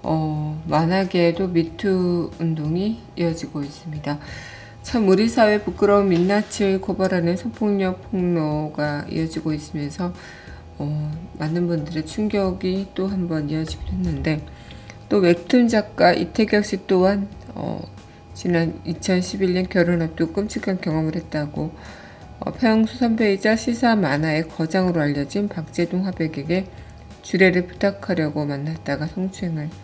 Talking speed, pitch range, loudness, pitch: 280 characters per minute, 155-195 Hz, -22 LUFS, 175 Hz